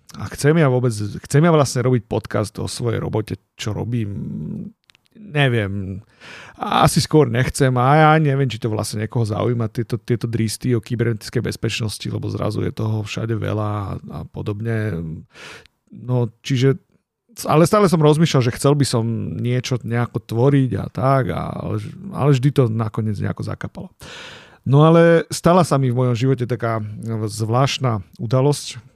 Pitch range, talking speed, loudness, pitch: 110-140 Hz, 155 wpm, -19 LUFS, 120 Hz